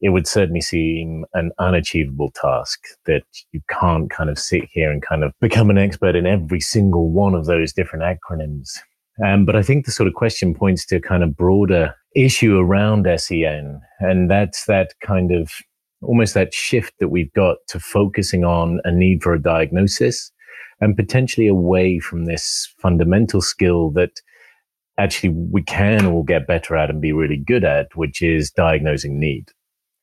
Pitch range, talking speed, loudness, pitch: 80-100 Hz, 175 wpm, -18 LUFS, 90 Hz